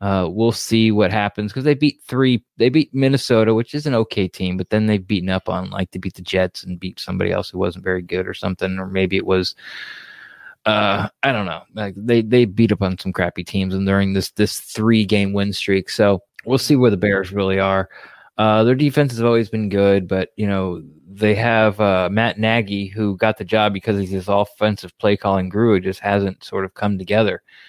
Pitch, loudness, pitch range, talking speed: 100 Hz, -19 LUFS, 95-110 Hz, 230 wpm